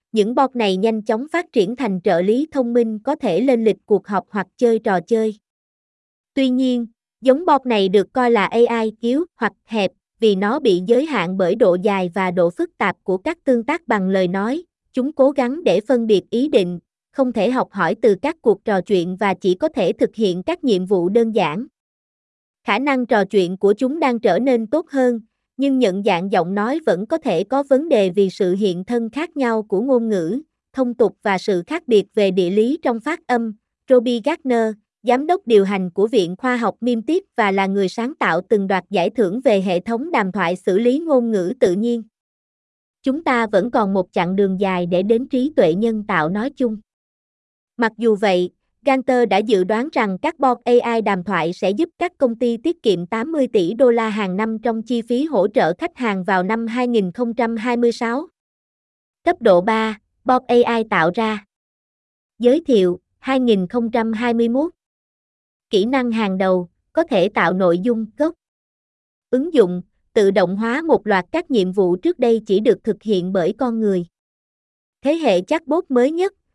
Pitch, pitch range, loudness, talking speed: 230 Hz, 195-255 Hz, -18 LUFS, 200 wpm